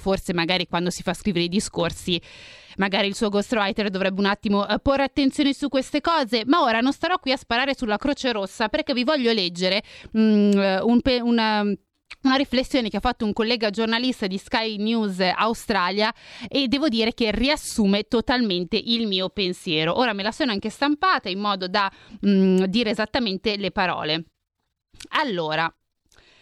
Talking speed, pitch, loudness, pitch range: 165 wpm, 220 Hz, -22 LUFS, 195-255 Hz